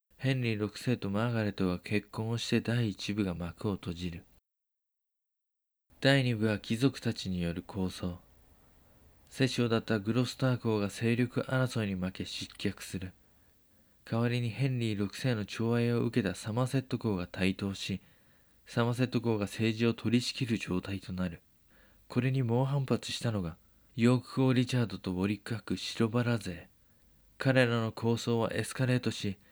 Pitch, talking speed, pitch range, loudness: 110 Hz, 295 characters per minute, 95-120 Hz, -32 LUFS